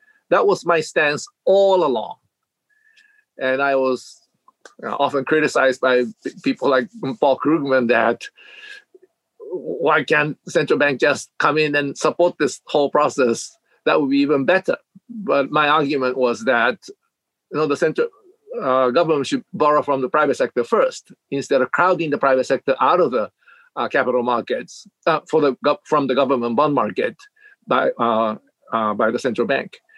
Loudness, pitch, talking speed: -19 LUFS, 155 Hz, 160 wpm